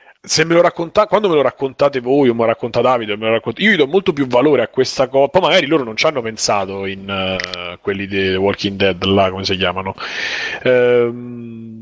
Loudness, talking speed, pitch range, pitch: -15 LUFS, 235 wpm, 100-135 Hz, 115 Hz